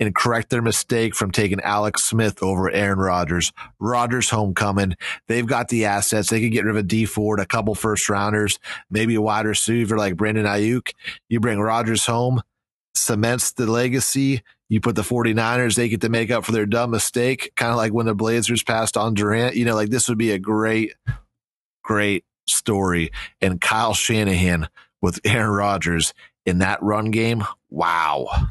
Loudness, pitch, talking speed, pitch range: -20 LUFS, 110 Hz, 180 wpm, 105-115 Hz